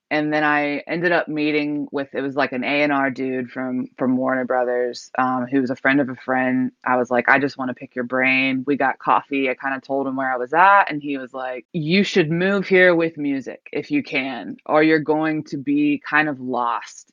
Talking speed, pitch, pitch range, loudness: 240 wpm, 140 Hz, 130-150 Hz, -20 LUFS